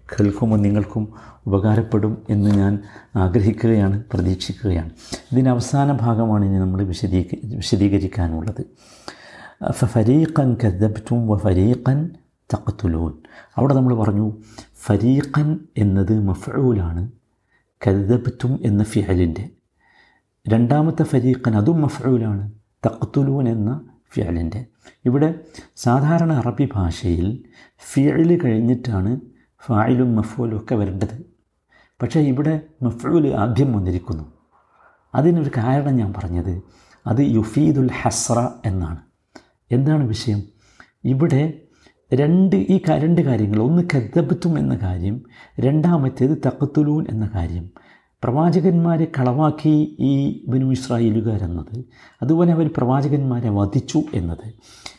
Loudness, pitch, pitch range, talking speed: -19 LUFS, 120 Hz, 105-140 Hz, 90 wpm